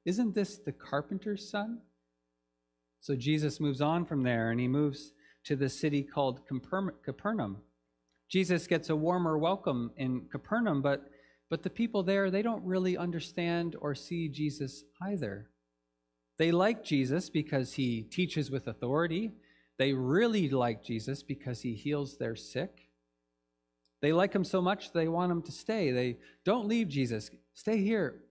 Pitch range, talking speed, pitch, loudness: 120-180 Hz, 155 wpm, 145 Hz, -33 LUFS